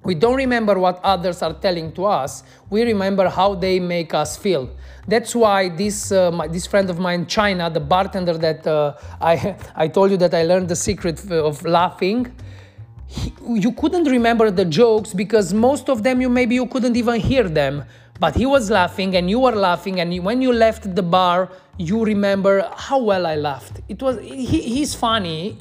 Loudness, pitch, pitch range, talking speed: -18 LUFS, 195 Hz, 170-225 Hz, 200 wpm